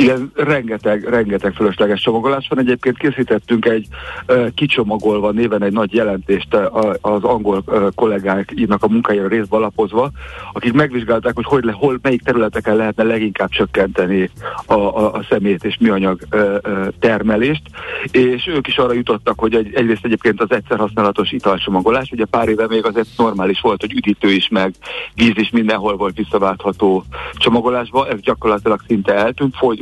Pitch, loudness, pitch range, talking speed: 110 Hz, -16 LUFS, 105-120 Hz, 150 wpm